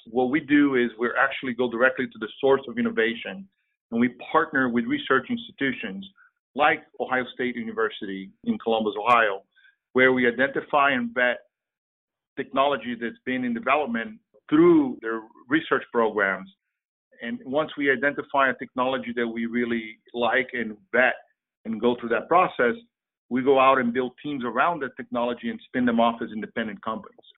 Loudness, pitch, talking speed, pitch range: -24 LUFS, 125 Hz, 160 wpm, 115-145 Hz